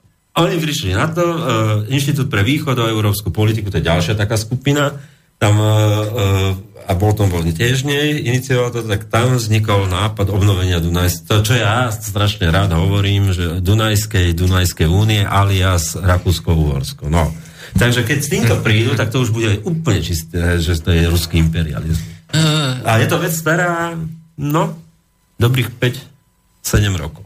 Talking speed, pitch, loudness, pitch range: 155 wpm, 105 Hz, -16 LUFS, 90-130 Hz